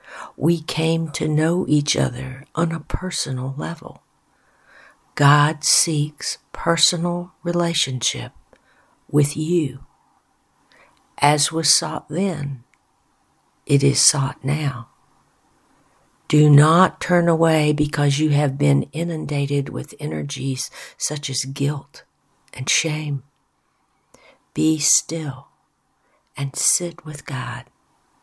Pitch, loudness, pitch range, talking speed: 150 Hz, -20 LUFS, 140-165 Hz, 100 wpm